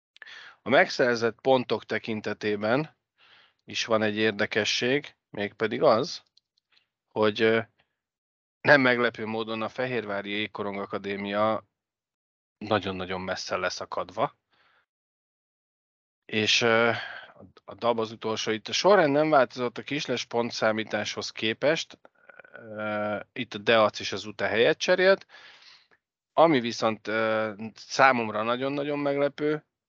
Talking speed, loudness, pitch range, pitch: 95 wpm, -26 LUFS, 105-120 Hz, 110 Hz